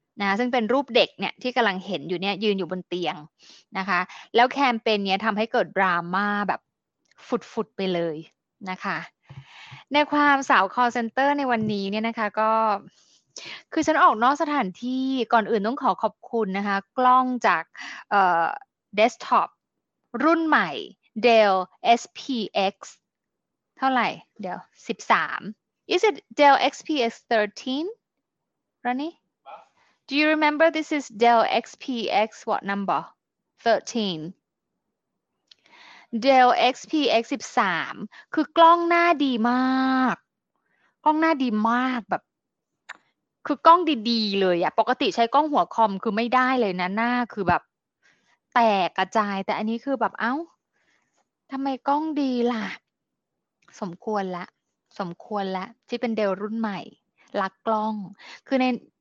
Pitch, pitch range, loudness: 235 Hz, 200-270 Hz, -23 LUFS